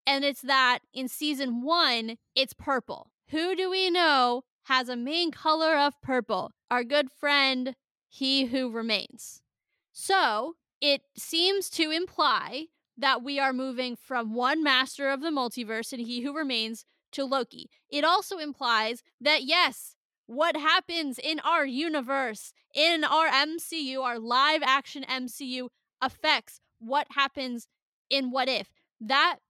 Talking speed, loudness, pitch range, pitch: 140 wpm, -27 LUFS, 255-310 Hz, 275 Hz